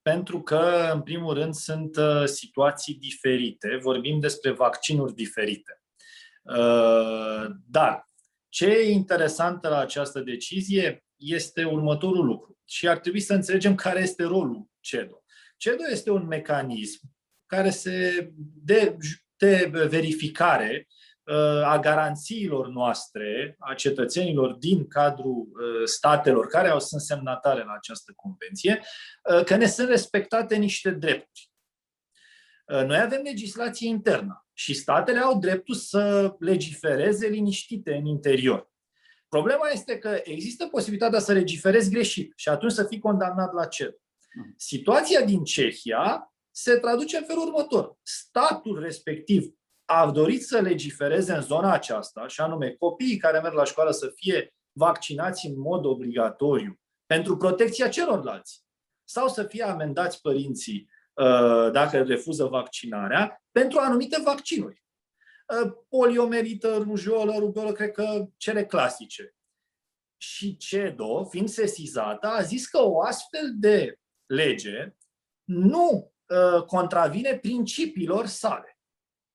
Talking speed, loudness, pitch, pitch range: 115 wpm, -25 LUFS, 185 Hz, 150-220 Hz